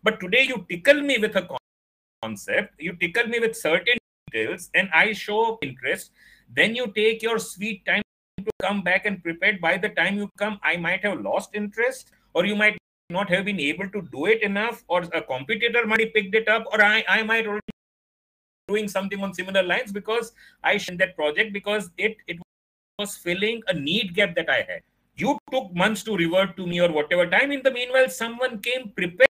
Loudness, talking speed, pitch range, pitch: -23 LUFS, 205 wpm, 185-225 Hz, 210 Hz